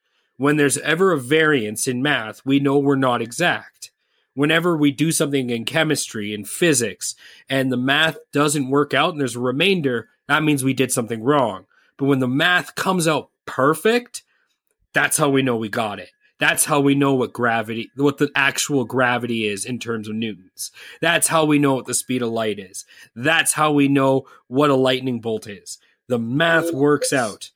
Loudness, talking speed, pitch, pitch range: -19 LUFS, 190 wpm, 140 Hz, 125-150 Hz